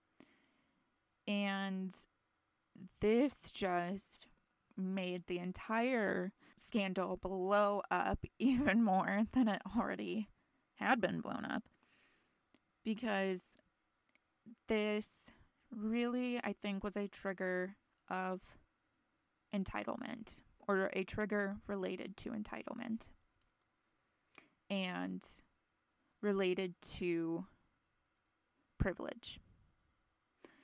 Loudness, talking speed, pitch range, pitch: -39 LUFS, 75 wpm, 185-220 Hz, 200 Hz